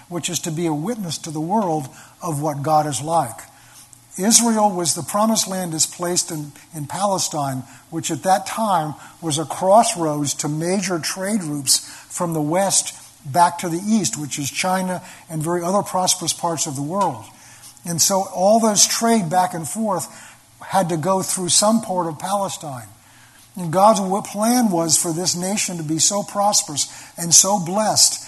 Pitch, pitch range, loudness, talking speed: 175 Hz, 155-195 Hz, -19 LUFS, 175 wpm